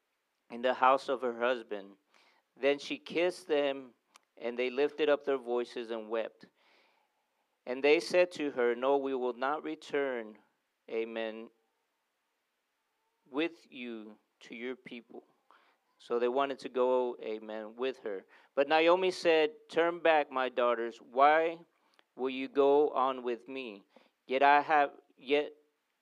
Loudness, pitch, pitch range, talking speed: -31 LUFS, 130 Hz, 120-150 Hz, 140 wpm